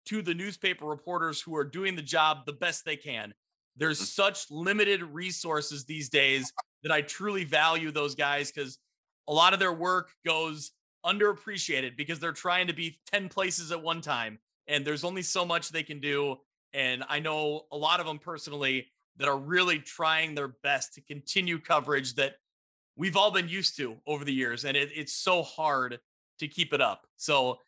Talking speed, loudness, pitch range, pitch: 190 wpm, -29 LUFS, 145-175 Hz, 155 Hz